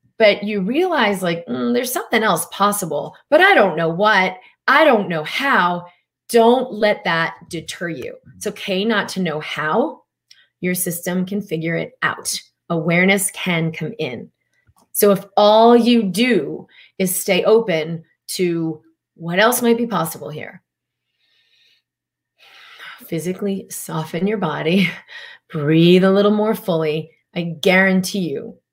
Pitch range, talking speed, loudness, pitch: 170-215 Hz, 140 wpm, -17 LUFS, 190 Hz